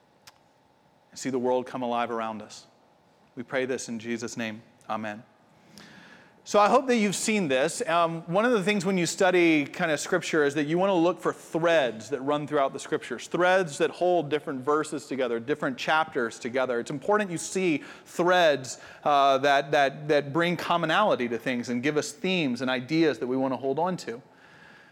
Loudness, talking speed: -26 LUFS, 195 wpm